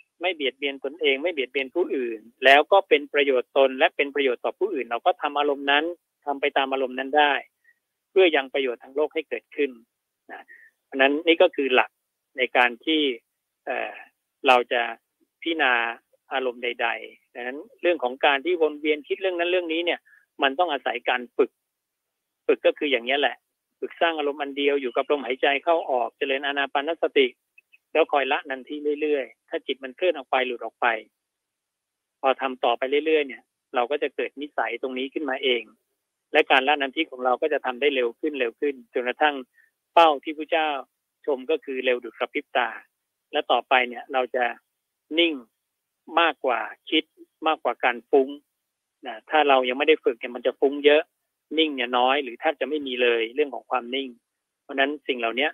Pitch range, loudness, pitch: 130-165 Hz, -24 LUFS, 145 Hz